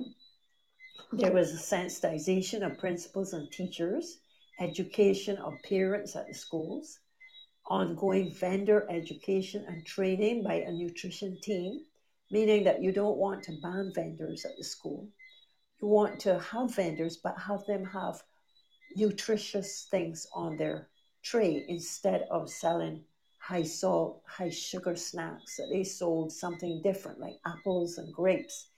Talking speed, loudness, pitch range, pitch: 135 wpm, -33 LUFS, 175-205 Hz, 190 Hz